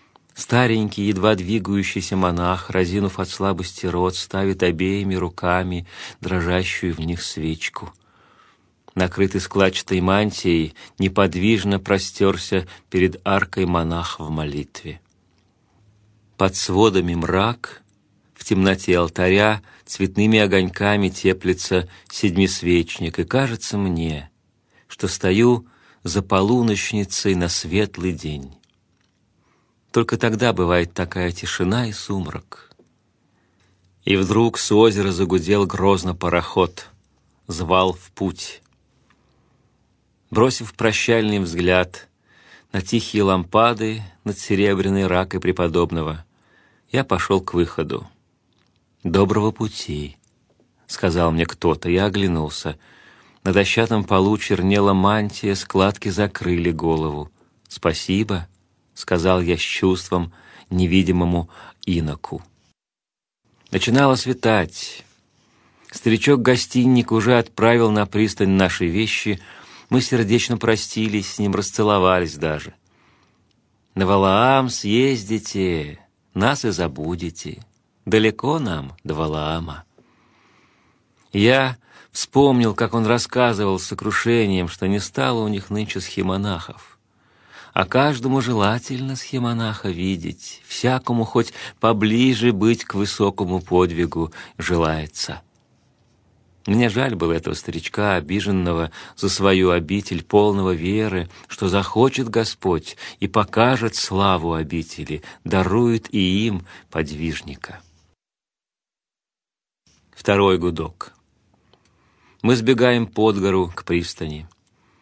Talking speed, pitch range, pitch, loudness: 95 wpm, 90-110 Hz, 95 Hz, -20 LUFS